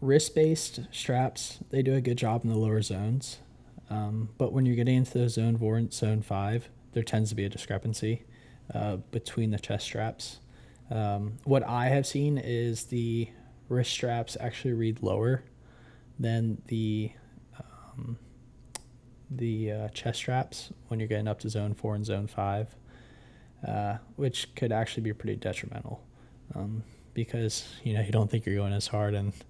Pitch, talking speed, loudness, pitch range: 115 Hz, 170 wpm, -31 LUFS, 110-125 Hz